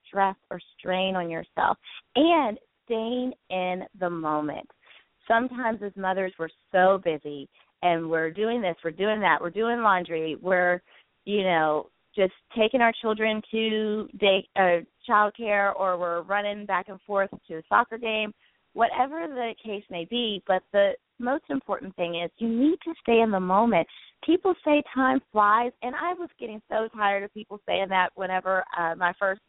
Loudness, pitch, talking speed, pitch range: -26 LUFS, 205 Hz, 170 wpm, 180-230 Hz